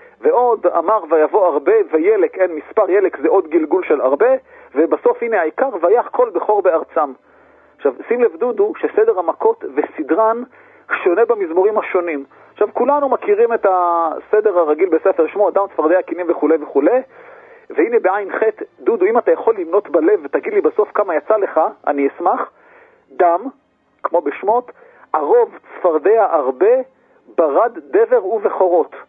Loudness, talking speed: -16 LUFS, 140 wpm